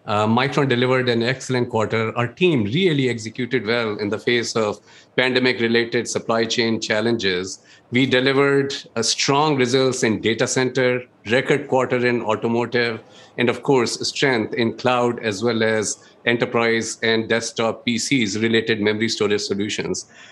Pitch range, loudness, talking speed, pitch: 110-125 Hz, -20 LUFS, 140 wpm, 120 Hz